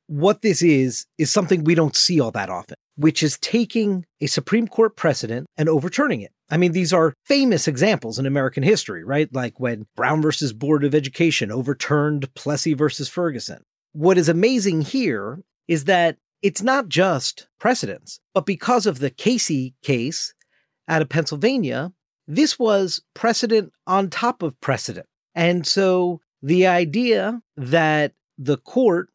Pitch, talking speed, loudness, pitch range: 165 Hz, 155 wpm, -20 LUFS, 145-195 Hz